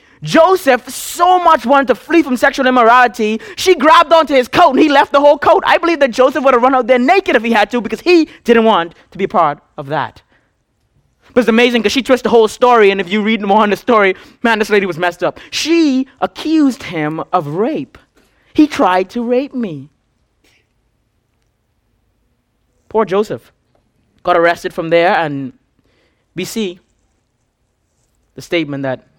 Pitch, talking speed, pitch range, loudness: 220 Hz, 180 wpm, 170-270 Hz, -12 LUFS